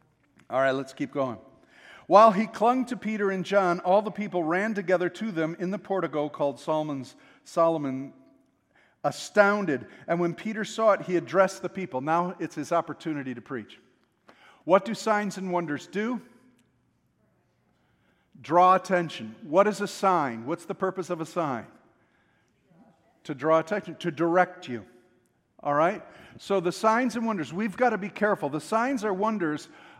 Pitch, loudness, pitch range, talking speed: 180 Hz, -26 LUFS, 150-205 Hz, 160 wpm